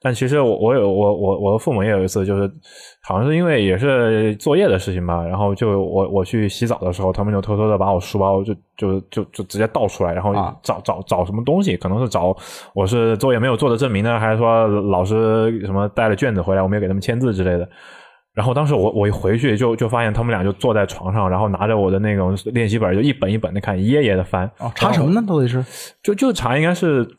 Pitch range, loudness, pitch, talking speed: 95-120 Hz, -18 LUFS, 105 Hz, 370 characters per minute